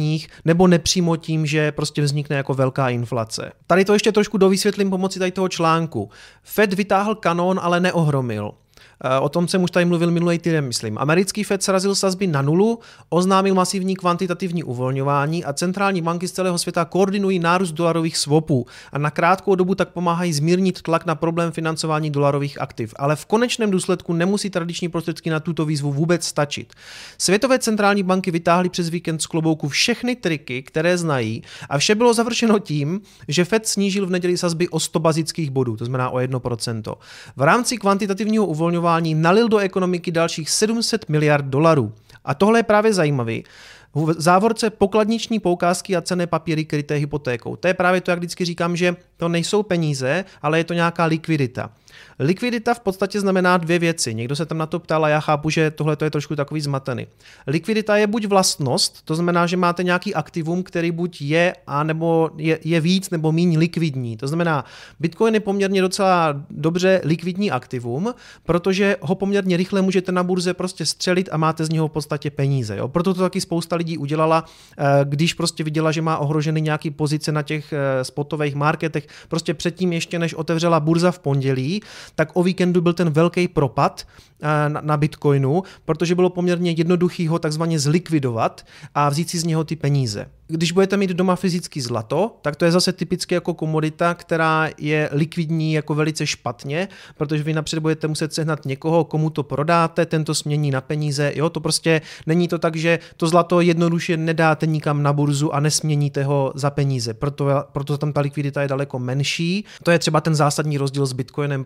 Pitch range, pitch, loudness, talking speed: 150-180 Hz, 165 Hz, -20 LUFS, 180 wpm